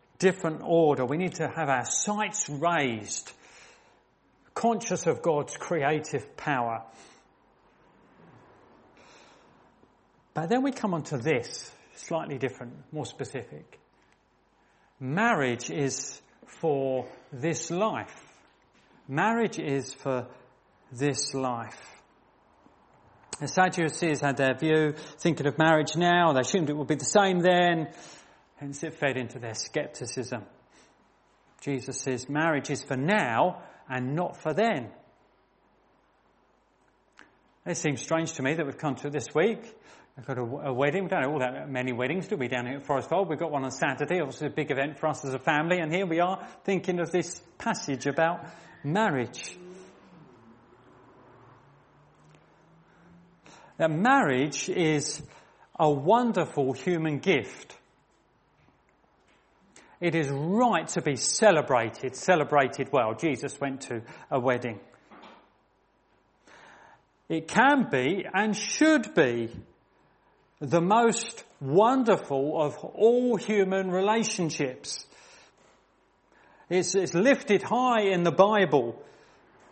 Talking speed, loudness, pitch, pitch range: 125 wpm, -27 LUFS, 155 Hz, 135-180 Hz